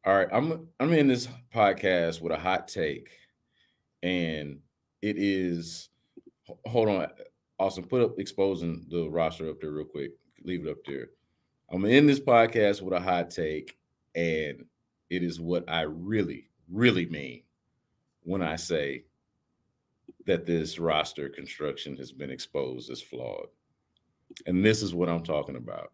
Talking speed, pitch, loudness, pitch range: 150 wpm, 90 Hz, -28 LUFS, 85-105 Hz